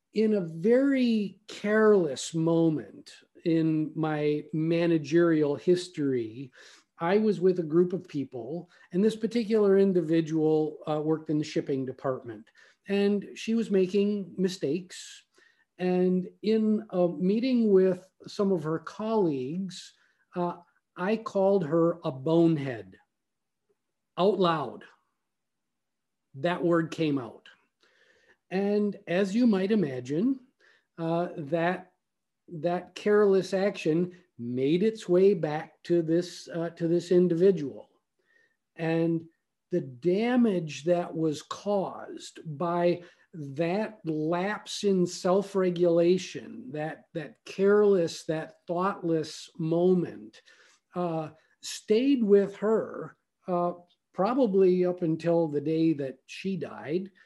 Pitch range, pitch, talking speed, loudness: 160-200 Hz, 175 Hz, 105 wpm, -27 LUFS